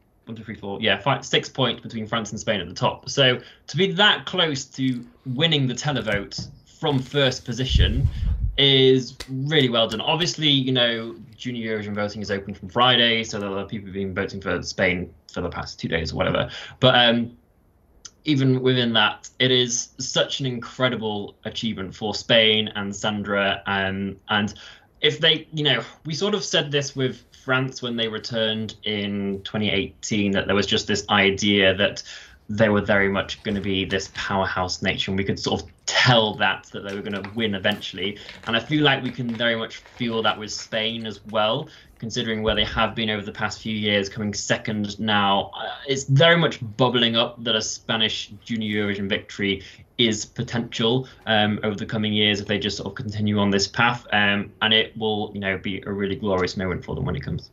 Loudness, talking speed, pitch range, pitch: -22 LUFS, 195 wpm, 100-125 Hz, 110 Hz